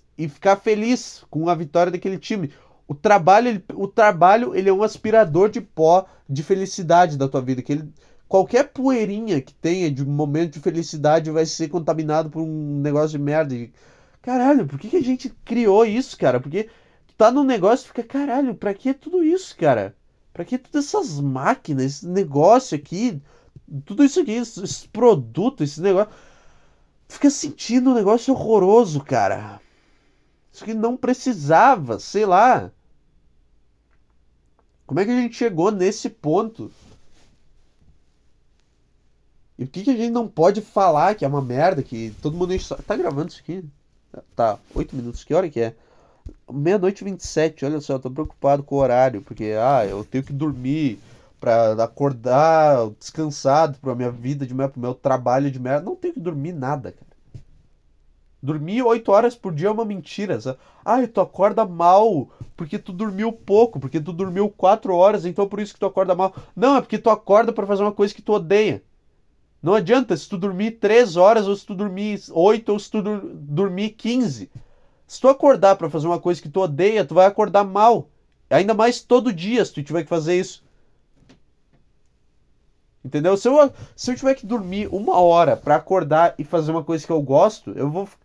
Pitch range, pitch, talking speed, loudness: 145-215 Hz, 180 Hz, 180 wpm, -19 LUFS